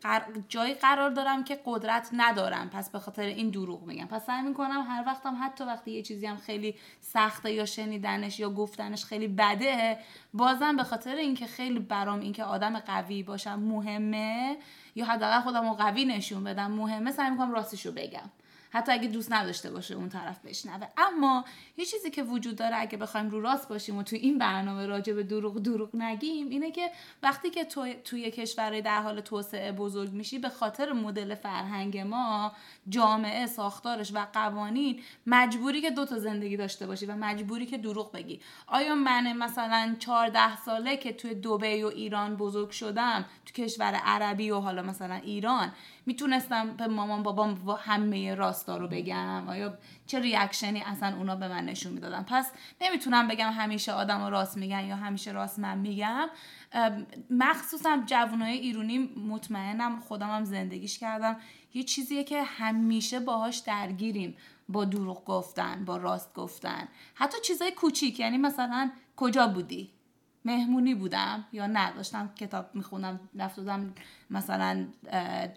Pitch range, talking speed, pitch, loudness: 205-250 Hz, 160 wpm, 220 Hz, -31 LUFS